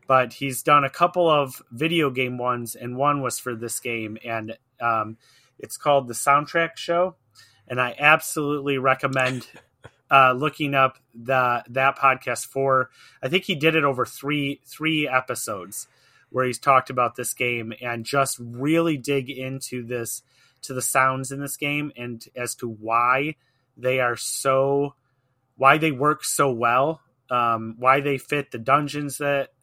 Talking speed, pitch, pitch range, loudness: 160 wpm, 130 Hz, 125-145 Hz, -22 LUFS